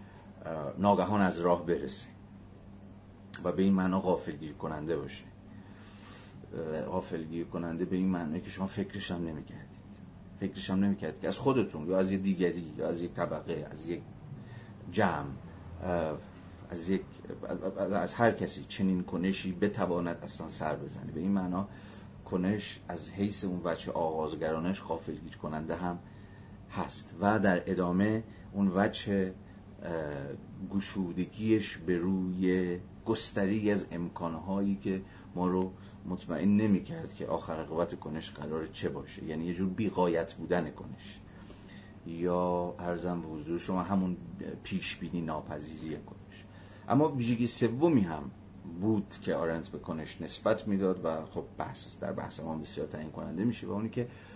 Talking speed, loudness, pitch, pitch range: 140 wpm, -33 LUFS, 95 Hz, 85-100 Hz